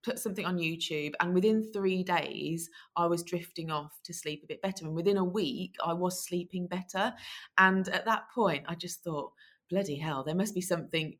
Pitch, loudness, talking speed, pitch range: 180 Hz, -32 LUFS, 205 wpm, 165-195 Hz